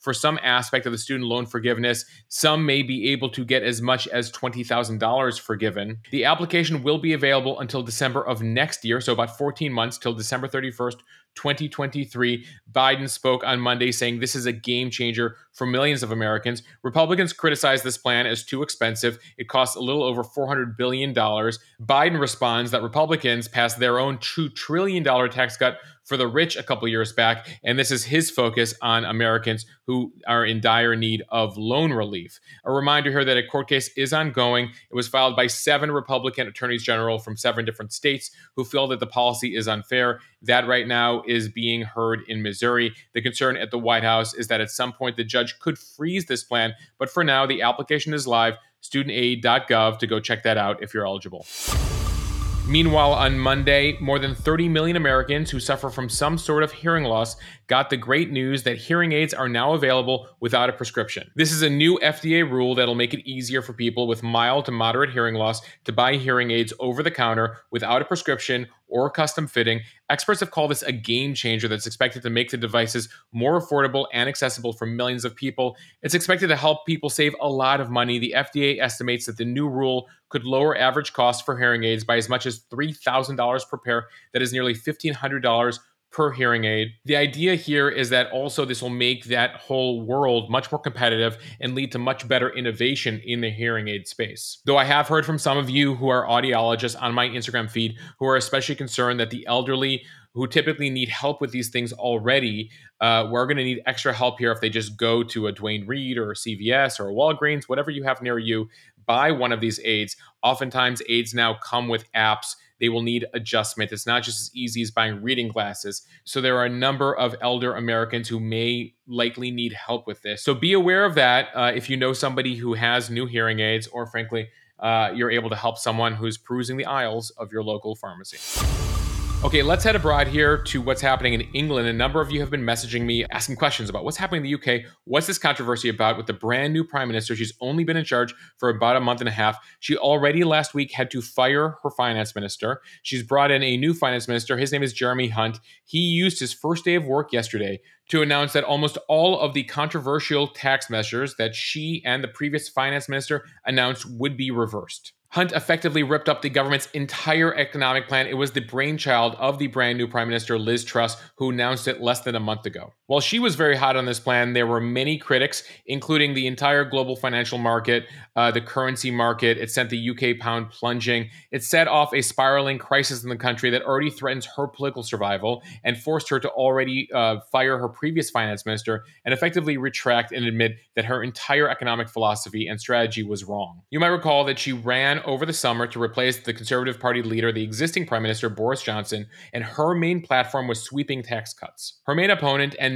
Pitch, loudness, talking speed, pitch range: 125 Hz, -22 LUFS, 210 wpm, 115-140 Hz